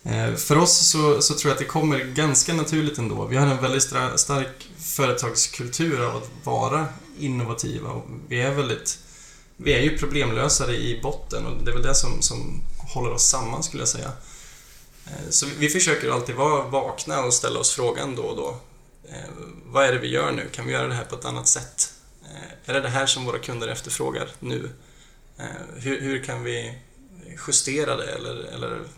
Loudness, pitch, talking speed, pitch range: -23 LUFS, 140 Hz, 190 wpm, 125-150 Hz